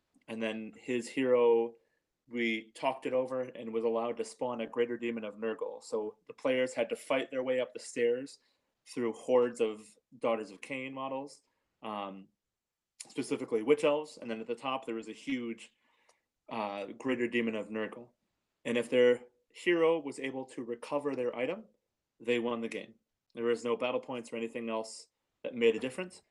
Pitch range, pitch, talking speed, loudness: 115-130 Hz, 120 Hz, 185 wpm, -34 LUFS